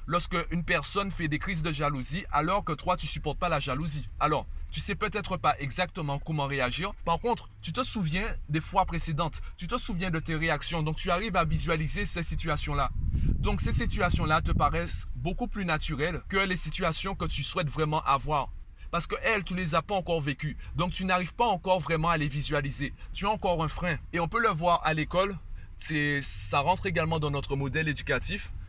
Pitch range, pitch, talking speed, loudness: 145-180 Hz, 165 Hz, 210 wpm, -29 LUFS